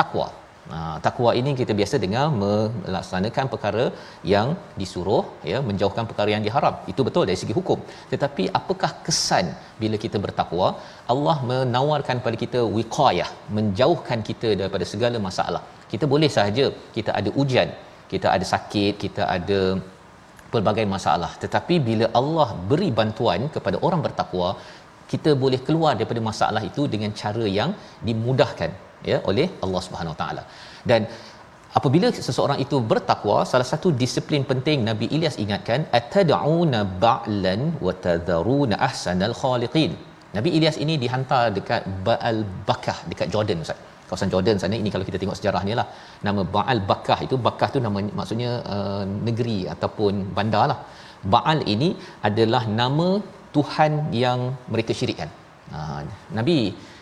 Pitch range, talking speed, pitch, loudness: 100-135 Hz, 140 wpm, 115 Hz, -23 LUFS